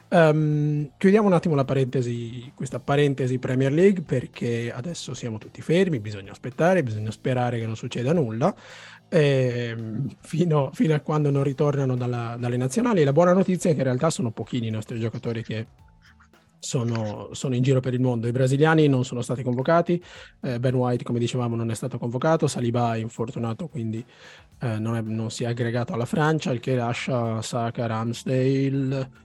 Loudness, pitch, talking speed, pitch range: -24 LUFS, 130 Hz, 175 wpm, 120-150 Hz